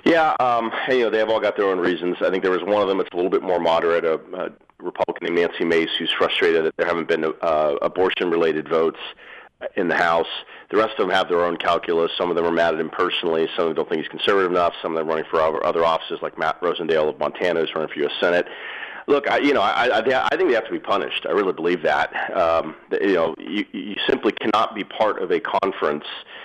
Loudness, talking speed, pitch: -21 LUFS, 260 wpm, 110 Hz